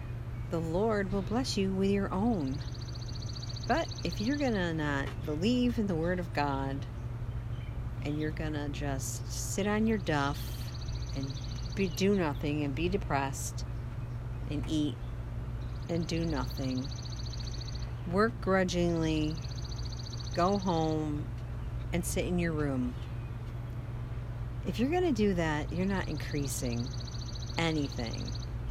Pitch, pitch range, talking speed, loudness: 125 Hz, 120-155 Hz, 125 wpm, -33 LUFS